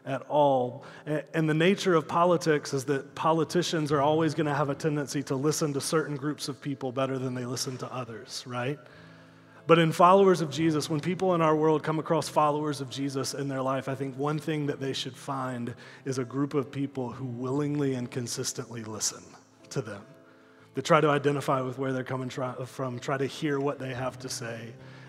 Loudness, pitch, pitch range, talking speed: -28 LUFS, 140 Hz, 130-155 Hz, 210 wpm